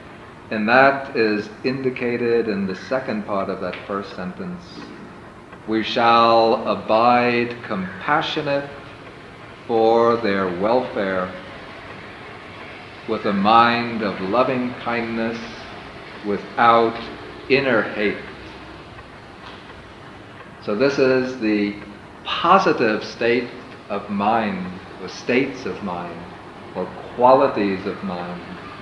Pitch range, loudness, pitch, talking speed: 100-125 Hz, -20 LUFS, 115 Hz, 90 wpm